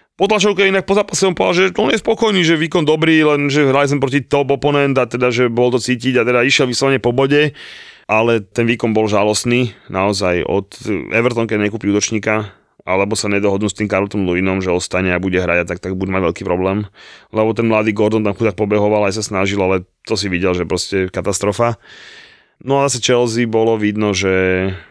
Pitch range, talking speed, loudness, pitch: 100-135 Hz, 210 wpm, -15 LUFS, 110 Hz